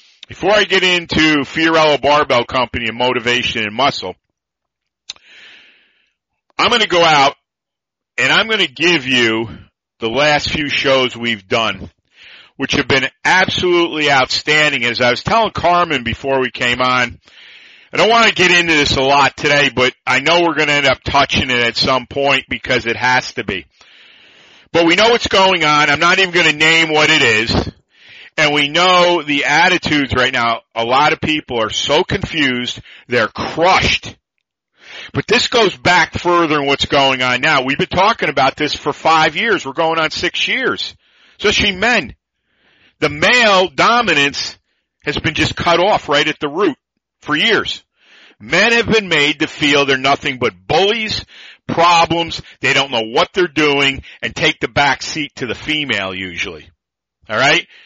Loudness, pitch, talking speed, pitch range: -13 LUFS, 145 Hz, 170 wpm, 125-170 Hz